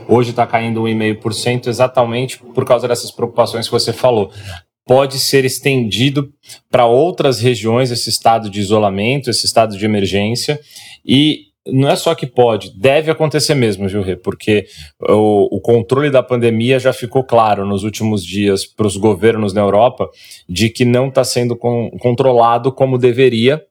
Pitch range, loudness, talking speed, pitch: 105-130 Hz, -14 LUFS, 155 wpm, 120 Hz